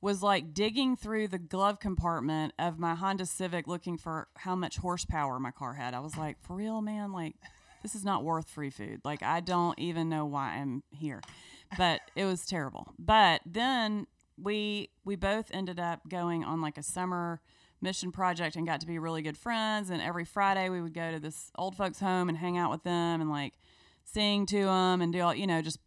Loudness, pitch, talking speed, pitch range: -32 LUFS, 175 Hz, 215 wpm, 160-195 Hz